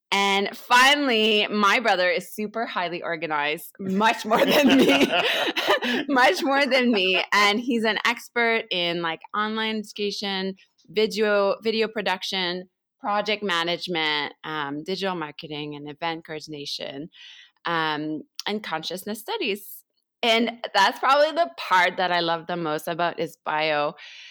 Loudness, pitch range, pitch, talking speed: -23 LUFS, 170-225 Hz, 200 Hz, 130 wpm